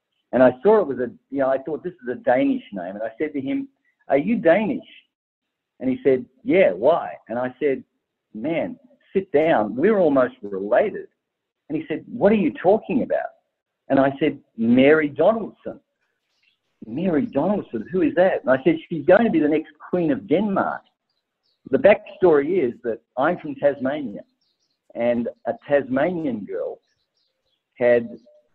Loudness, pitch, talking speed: -21 LUFS, 175 Hz, 170 wpm